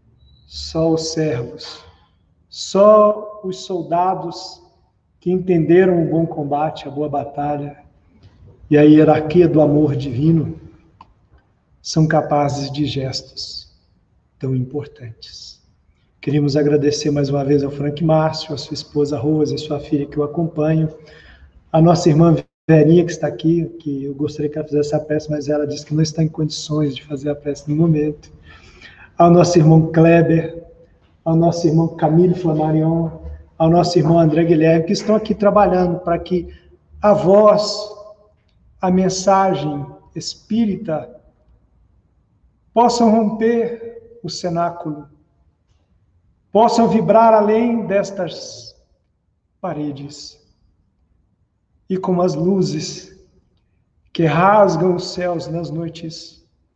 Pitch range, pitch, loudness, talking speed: 145-175 Hz, 155 Hz, -16 LUFS, 125 wpm